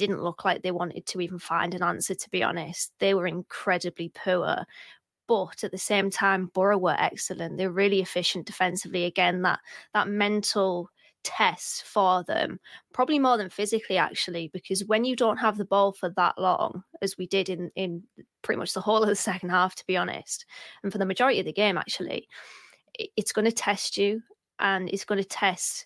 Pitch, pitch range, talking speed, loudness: 195 Hz, 180-210 Hz, 195 wpm, -27 LUFS